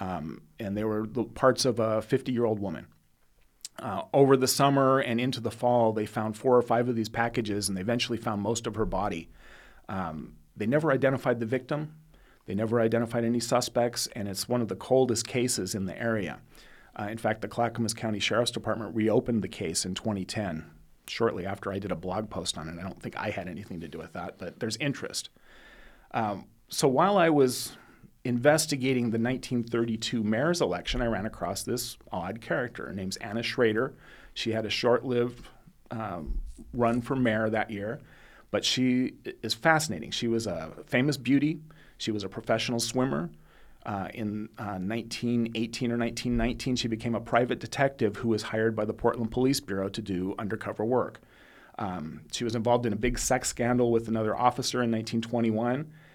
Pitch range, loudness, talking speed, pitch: 110-125 Hz, -29 LUFS, 185 wpm, 115 Hz